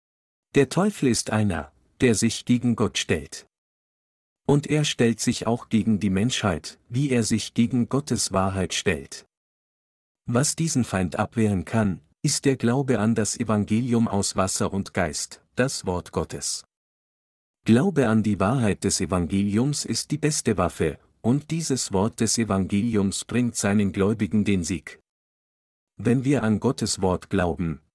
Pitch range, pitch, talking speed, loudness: 100-125 Hz, 110 Hz, 145 wpm, -24 LUFS